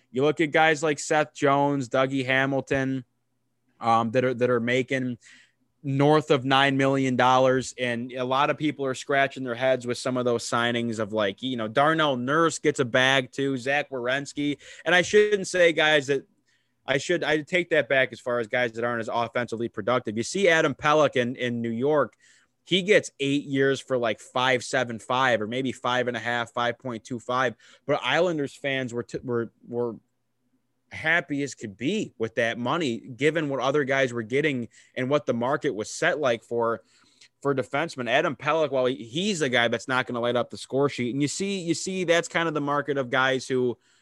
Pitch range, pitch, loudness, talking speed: 120-145 Hz, 130 Hz, -25 LUFS, 205 wpm